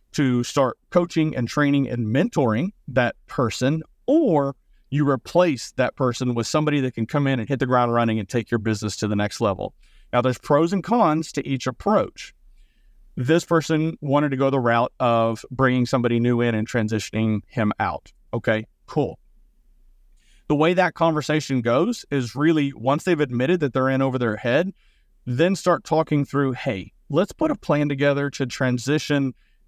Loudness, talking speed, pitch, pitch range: -22 LUFS, 175 wpm, 135 Hz, 120-150 Hz